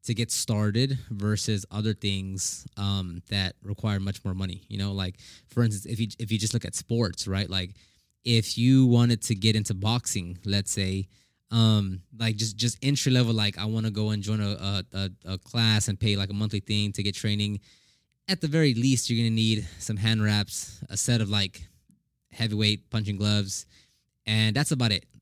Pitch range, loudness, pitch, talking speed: 100-115 Hz, -27 LUFS, 105 Hz, 195 wpm